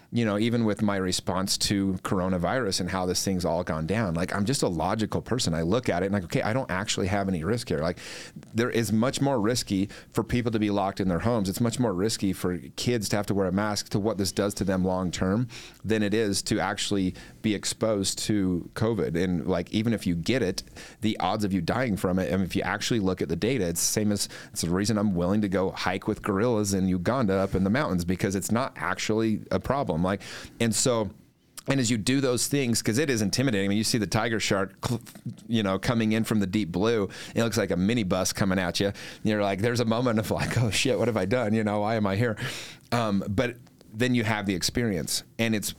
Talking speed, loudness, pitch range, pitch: 255 wpm, -26 LUFS, 95-115 Hz, 105 Hz